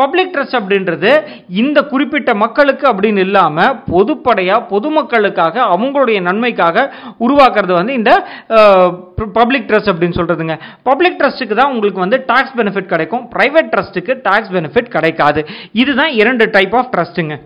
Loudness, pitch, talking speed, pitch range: -12 LUFS, 225 Hz, 125 wpm, 185-265 Hz